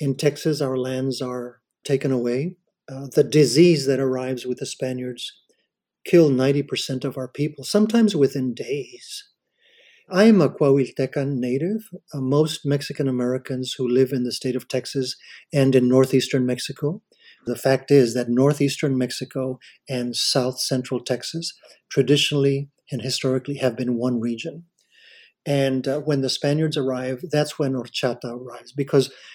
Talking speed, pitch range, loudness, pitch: 145 wpm, 130-150 Hz, -22 LUFS, 135 Hz